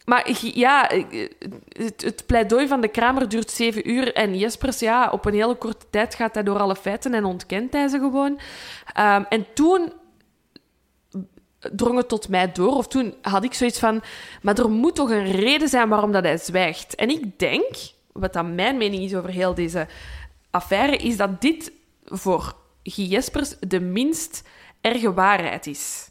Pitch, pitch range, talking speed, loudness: 225 Hz, 195-255 Hz, 170 wpm, -22 LUFS